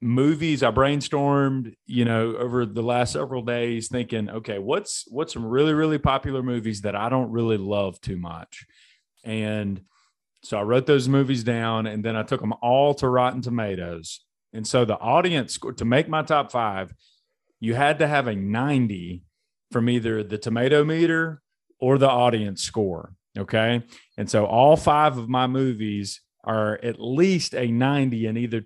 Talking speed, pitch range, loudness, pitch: 170 wpm, 110-135 Hz, -23 LUFS, 120 Hz